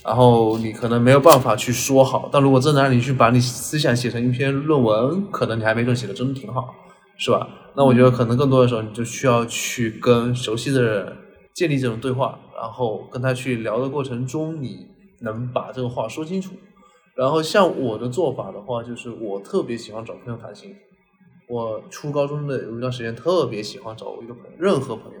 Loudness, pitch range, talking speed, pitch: -20 LUFS, 120-140 Hz, 320 characters per minute, 125 Hz